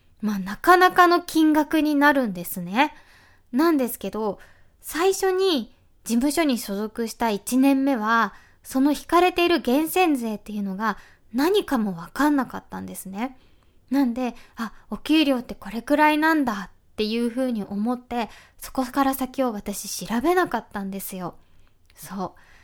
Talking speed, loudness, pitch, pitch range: 300 characters per minute, -23 LUFS, 245 Hz, 210-295 Hz